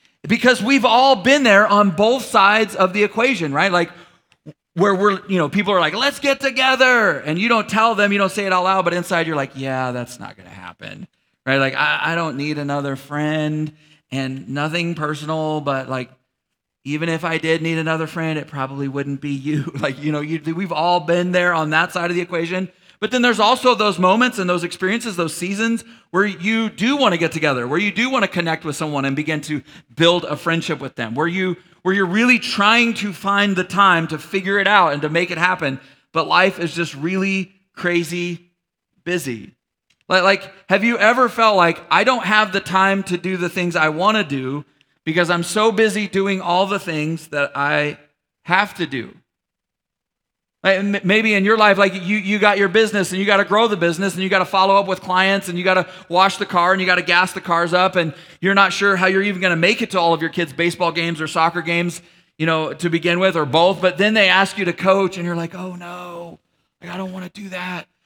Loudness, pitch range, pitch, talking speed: -17 LUFS, 160-200 Hz, 180 Hz, 230 wpm